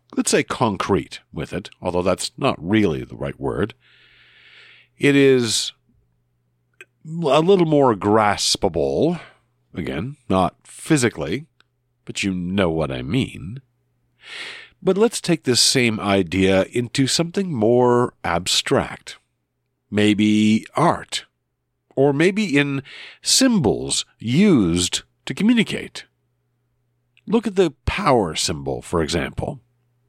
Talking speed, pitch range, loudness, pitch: 105 wpm, 90-145 Hz, -19 LUFS, 120 Hz